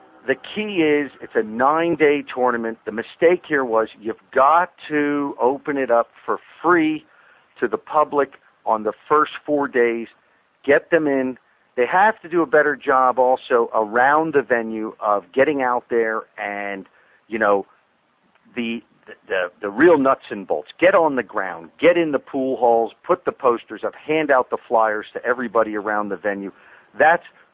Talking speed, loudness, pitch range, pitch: 170 wpm, -20 LUFS, 110-150 Hz, 125 Hz